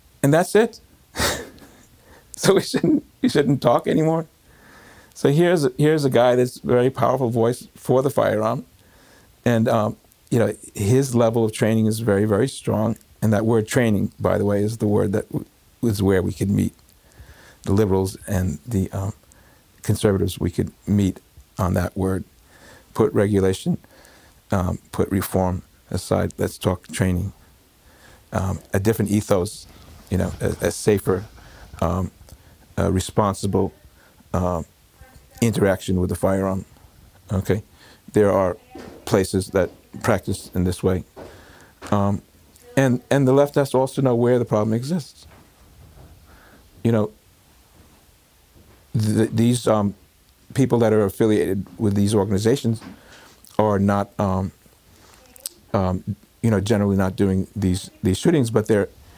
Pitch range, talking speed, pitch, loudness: 95-115 Hz, 140 wpm, 100 Hz, -21 LUFS